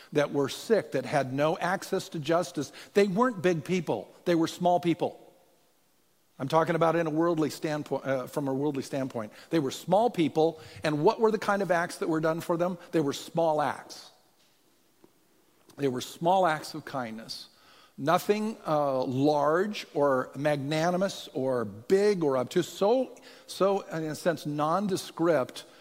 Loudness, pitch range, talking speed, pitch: -28 LUFS, 140-180 Hz, 165 wpm, 160 Hz